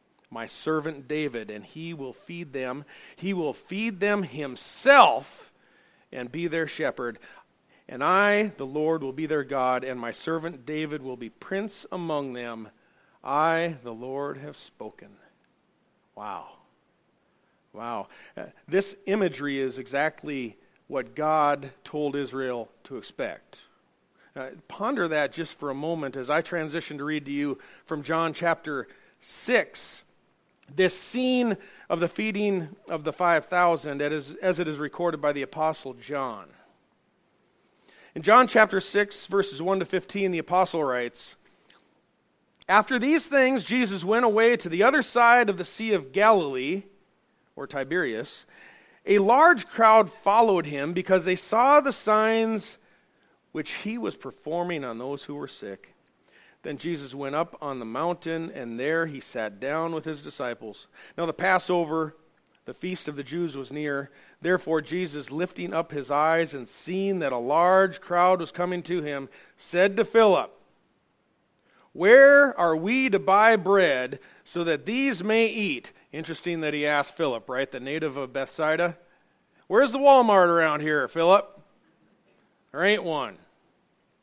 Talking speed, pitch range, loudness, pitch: 145 wpm, 145-195 Hz, -24 LUFS, 165 Hz